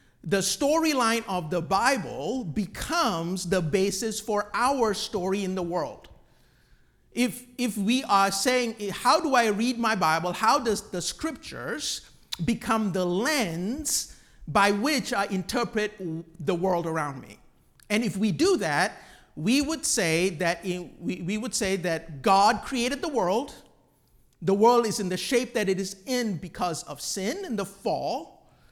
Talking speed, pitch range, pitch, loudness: 160 wpm, 185-240 Hz, 205 Hz, -26 LUFS